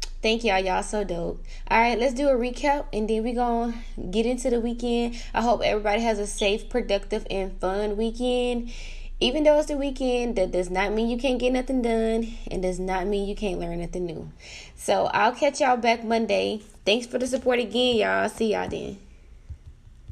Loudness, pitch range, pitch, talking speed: -25 LUFS, 200-245 Hz, 225 Hz, 200 wpm